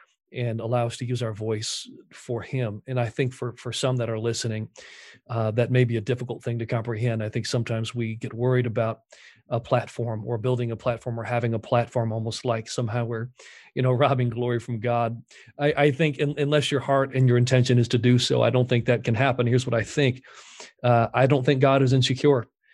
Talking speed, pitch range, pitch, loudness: 225 wpm, 115-130 Hz, 120 Hz, -24 LUFS